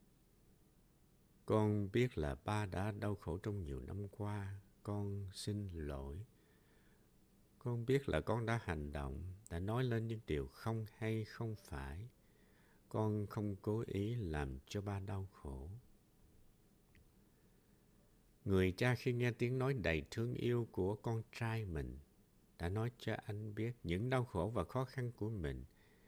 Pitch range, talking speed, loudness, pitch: 90-115 Hz, 150 wpm, -41 LUFS, 105 Hz